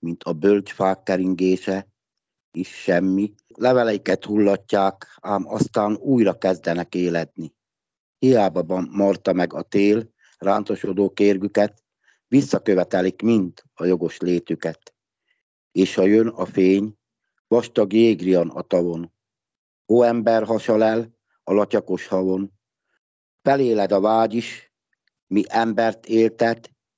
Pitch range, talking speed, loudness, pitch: 95-115 Hz, 110 wpm, -21 LUFS, 100 Hz